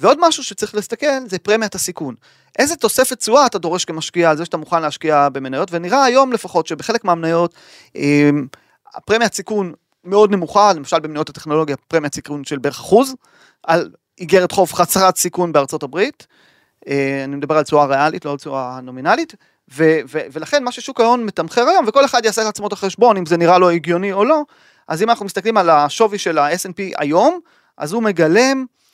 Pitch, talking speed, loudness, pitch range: 185 Hz, 170 wpm, -16 LUFS, 155-230 Hz